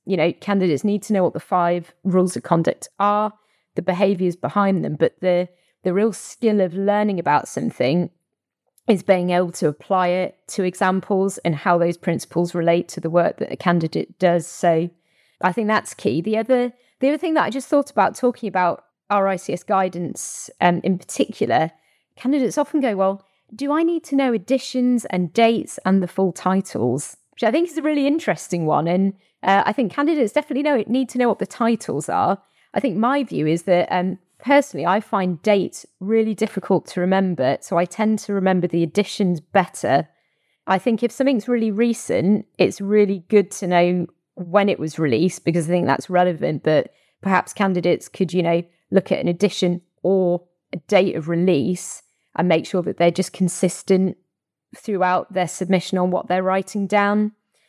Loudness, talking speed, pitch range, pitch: -20 LUFS, 185 wpm, 175-215 Hz, 190 Hz